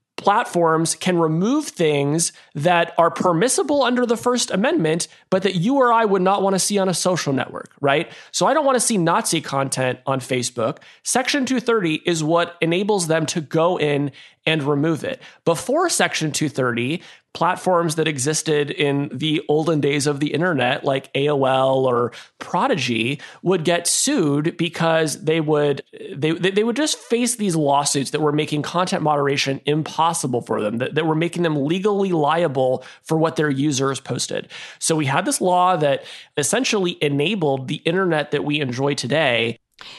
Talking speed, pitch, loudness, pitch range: 170 wpm, 160 Hz, -20 LUFS, 145-180 Hz